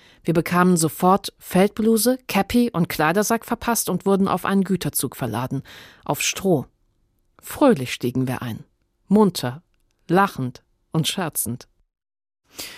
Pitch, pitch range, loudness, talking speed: 170 Hz, 125-195 Hz, -21 LUFS, 115 wpm